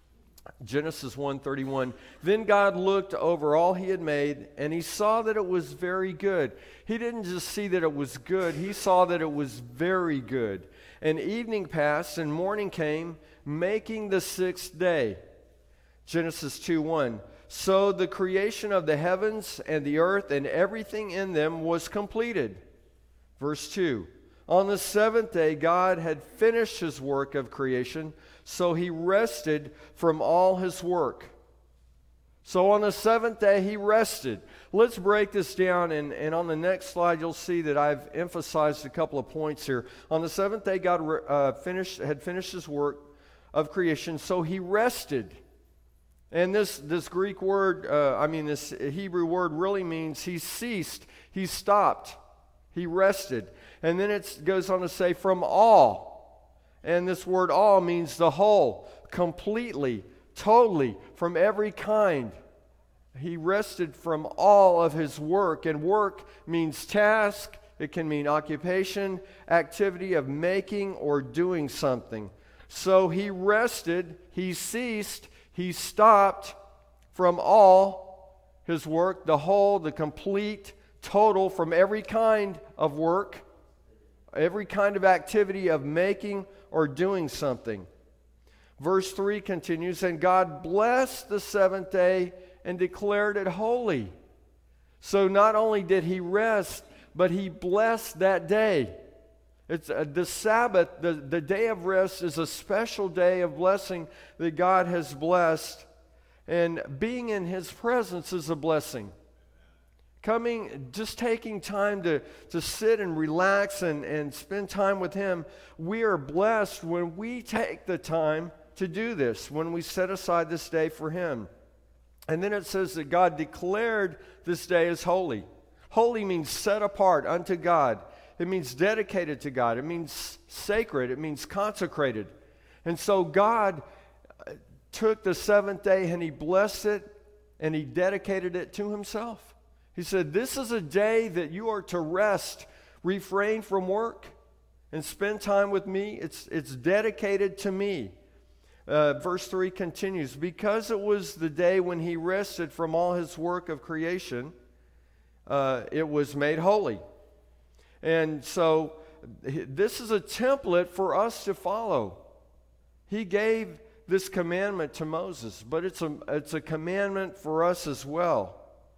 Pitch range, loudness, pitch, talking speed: 155-200 Hz, -27 LUFS, 180 Hz, 150 wpm